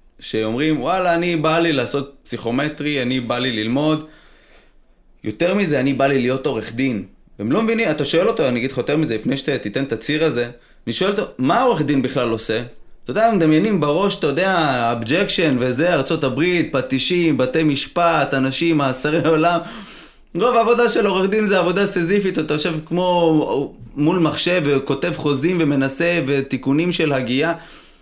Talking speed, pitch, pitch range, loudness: 165 wpm, 155 Hz, 135-170 Hz, -18 LUFS